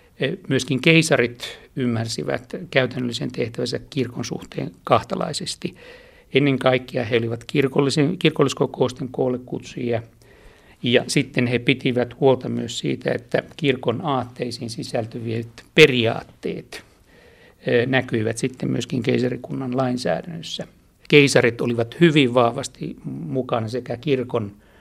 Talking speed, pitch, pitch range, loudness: 90 wpm, 125 Hz, 120-135 Hz, -21 LUFS